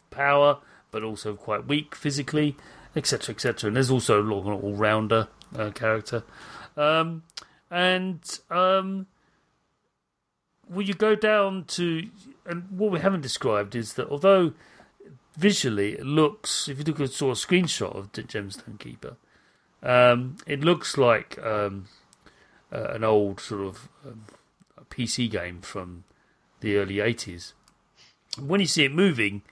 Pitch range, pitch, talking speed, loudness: 105-170 Hz, 135 Hz, 145 wpm, -25 LUFS